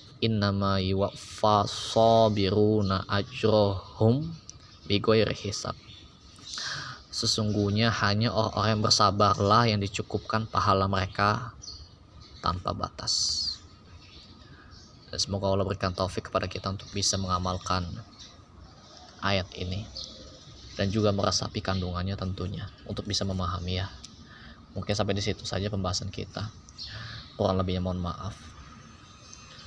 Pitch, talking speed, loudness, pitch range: 100 Hz, 95 wpm, -27 LUFS, 95-105 Hz